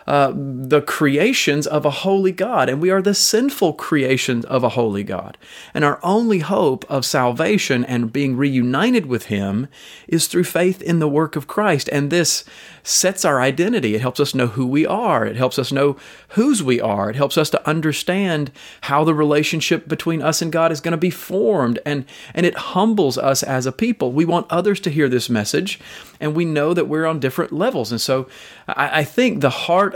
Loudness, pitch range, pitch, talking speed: -18 LUFS, 130-175 Hz, 150 Hz, 205 wpm